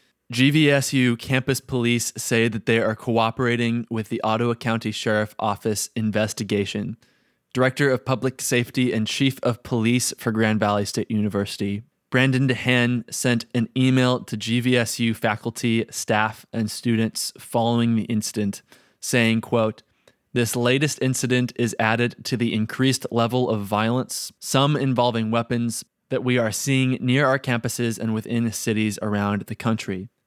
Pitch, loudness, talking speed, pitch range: 115 Hz, -22 LUFS, 140 wpm, 110-125 Hz